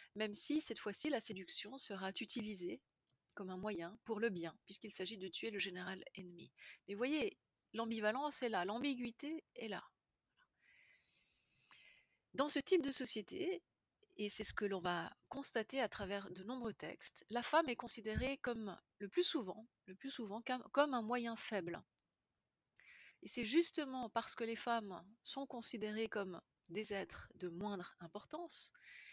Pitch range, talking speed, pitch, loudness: 200-260 Hz, 155 wpm, 225 Hz, -40 LUFS